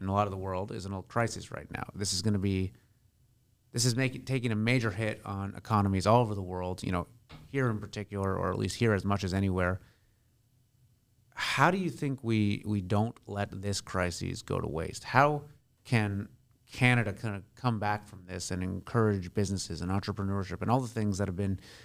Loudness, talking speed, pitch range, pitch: -31 LUFS, 210 wpm, 95-120 Hz, 105 Hz